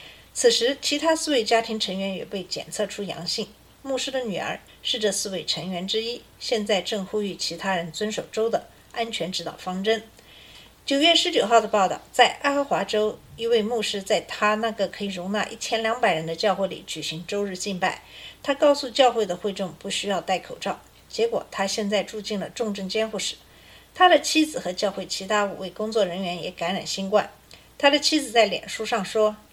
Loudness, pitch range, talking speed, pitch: -24 LUFS, 190-235 Hz, 295 characters per minute, 210 Hz